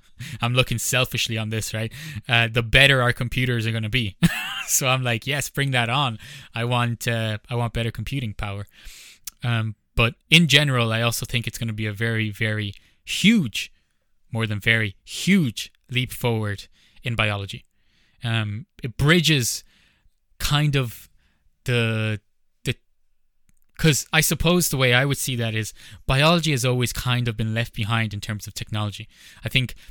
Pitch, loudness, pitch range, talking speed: 115 Hz, -22 LUFS, 110-130 Hz, 170 wpm